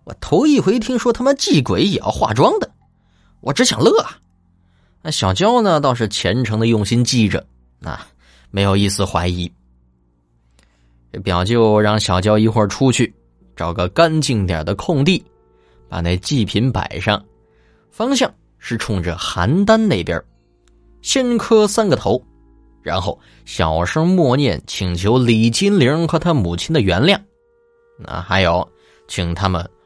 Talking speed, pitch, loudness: 205 characters per minute, 105 Hz, -16 LUFS